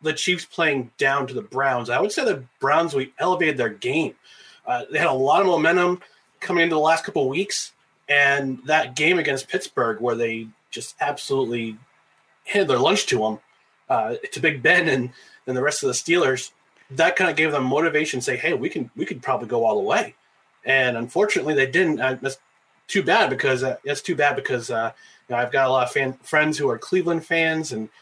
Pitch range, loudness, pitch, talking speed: 130-160 Hz, -21 LUFS, 140 Hz, 225 wpm